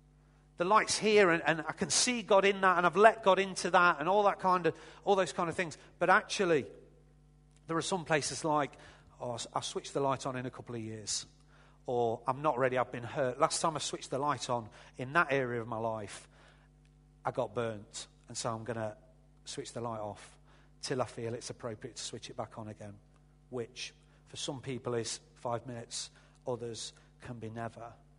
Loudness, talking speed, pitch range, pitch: -32 LUFS, 210 wpm, 120-160 Hz, 145 Hz